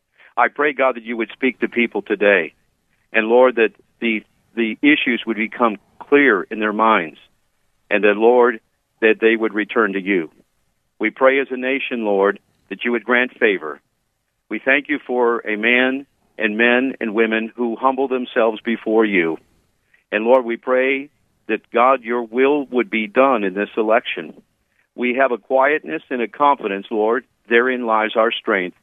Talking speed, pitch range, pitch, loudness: 175 wpm, 110-130 Hz, 120 Hz, -18 LUFS